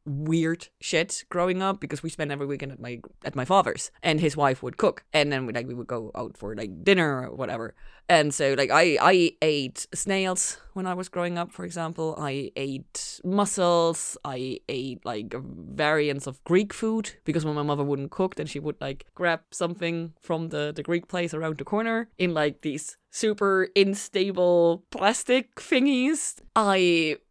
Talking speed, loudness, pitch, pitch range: 185 wpm, -26 LUFS, 165 Hz, 145-185 Hz